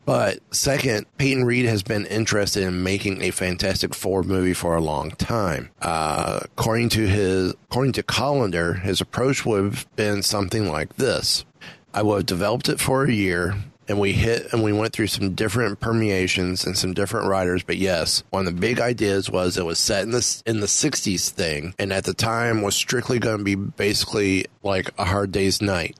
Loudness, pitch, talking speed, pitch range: -22 LUFS, 100 Hz, 200 wpm, 95-115 Hz